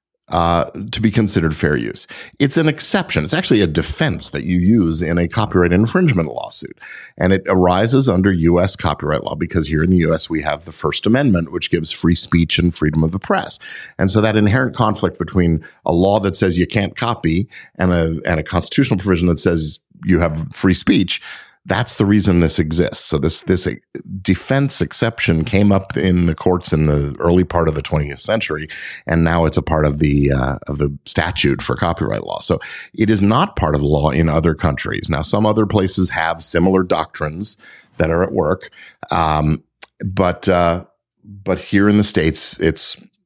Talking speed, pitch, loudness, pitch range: 195 wpm, 90 Hz, -16 LUFS, 80-100 Hz